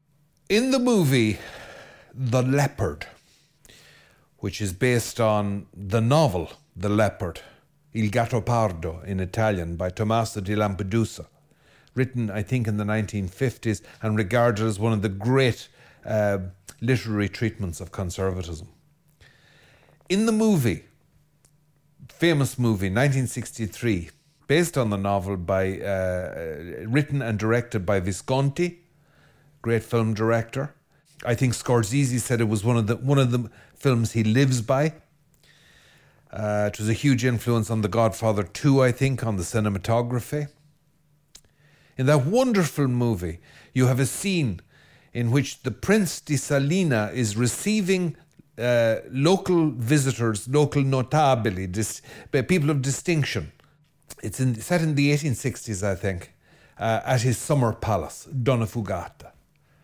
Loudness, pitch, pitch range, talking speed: -24 LUFS, 120 Hz, 110-145 Hz, 130 wpm